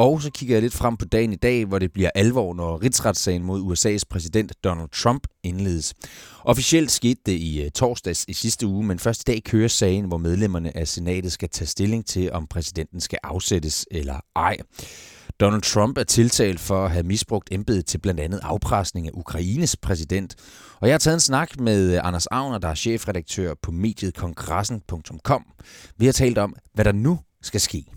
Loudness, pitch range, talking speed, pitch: -22 LUFS, 90-115 Hz, 195 wpm, 95 Hz